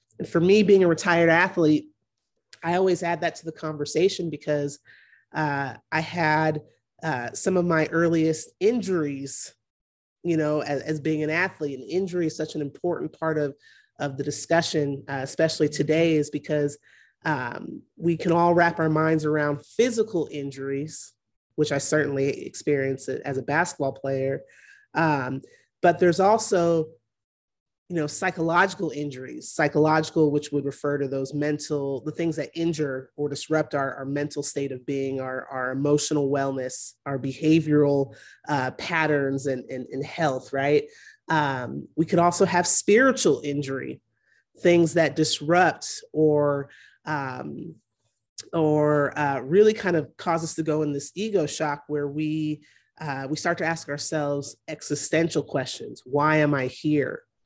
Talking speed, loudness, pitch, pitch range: 150 wpm, -24 LUFS, 150 Hz, 140-165 Hz